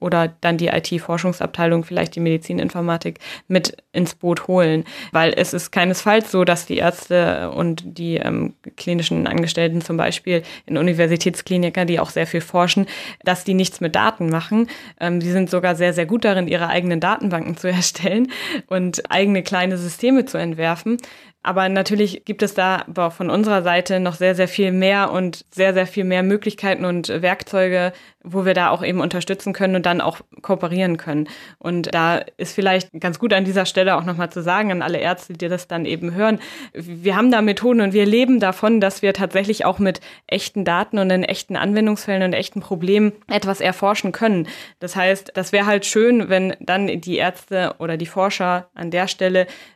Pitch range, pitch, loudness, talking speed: 175-195 Hz, 185 Hz, -19 LUFS, 185 wpm